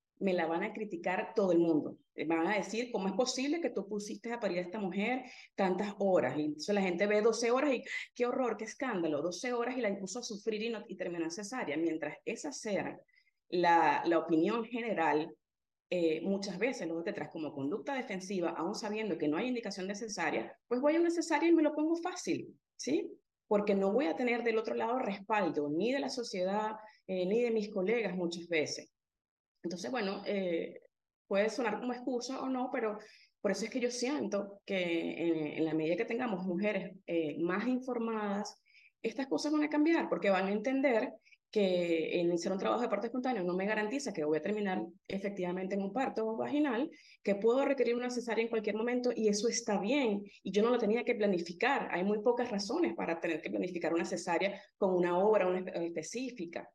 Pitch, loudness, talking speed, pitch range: 210 Hz, -34 LUFS, 205 wpm, 180-245 Hz